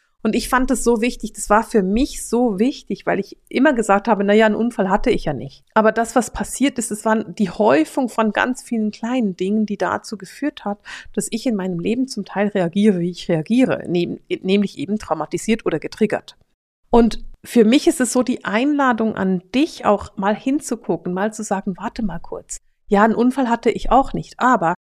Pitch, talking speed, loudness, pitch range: 220 Hz, 205 wpm, -19 LUFS, 200-245 Hz